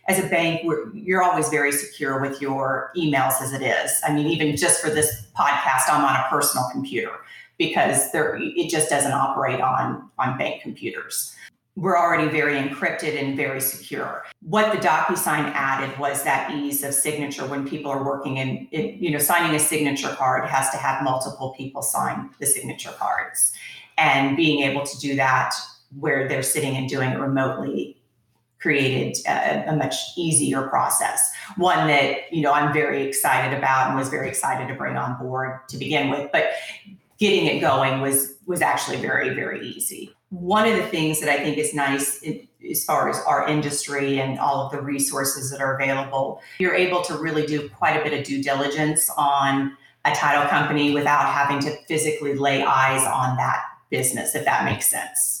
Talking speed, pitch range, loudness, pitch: 185 wpm, 135-155 Hz, -22 LUFS, 140 Hz